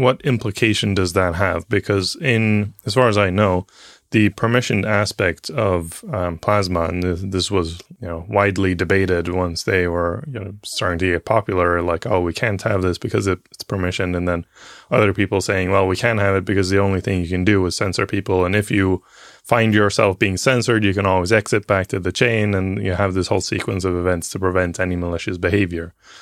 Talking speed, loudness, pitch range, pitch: 215 wpm, -19 LUFS, 90-105 Hz, 95 Hz